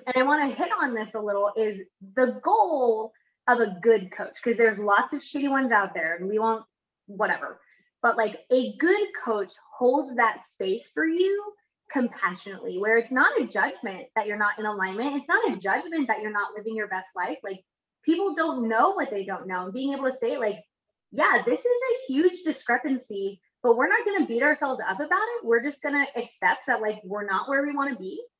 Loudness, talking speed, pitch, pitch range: -25 LUFS, 215 wpm, 245 Hz, 210-295 Hz